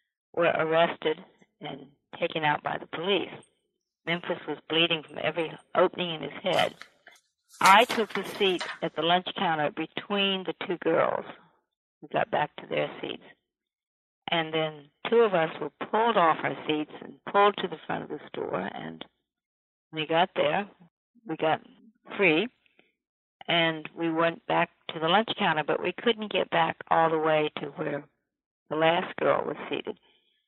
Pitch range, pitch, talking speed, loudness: 155-190 Hz, 165 Hz, 165 wpm, -27 LUFS